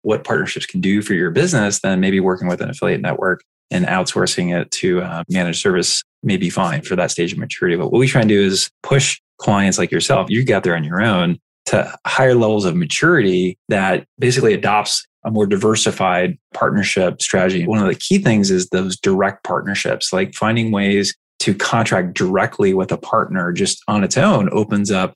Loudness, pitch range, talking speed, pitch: -17 LUFS, 95-110 Hz, 200 wpm, 100 Hz